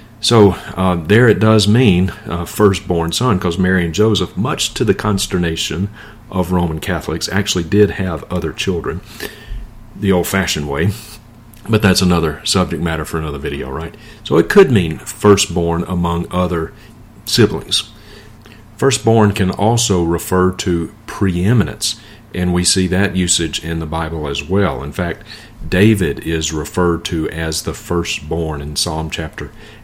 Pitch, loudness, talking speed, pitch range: 95 Hz, -16 LUFS, 150 wpm, 85-105 Hz